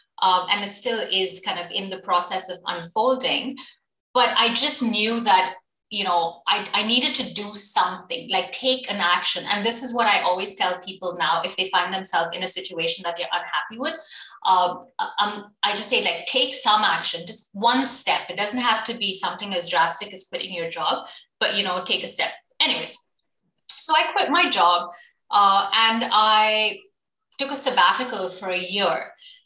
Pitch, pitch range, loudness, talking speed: 205 Hz, 180-245 Hz, -21 LUFS, 190 wpm